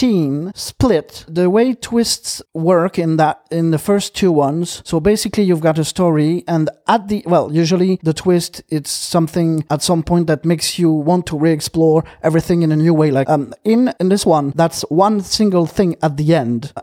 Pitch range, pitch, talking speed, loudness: 155-185 Hz, 170 Hz, 195 wpm, -16 LUFS